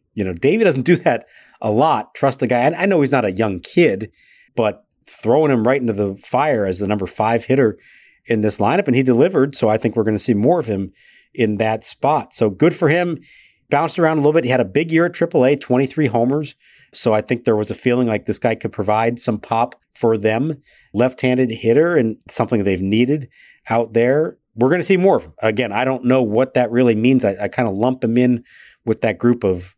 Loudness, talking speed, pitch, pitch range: -17 LUFS, 240 wpm, 120 Hz, 110-130 Hz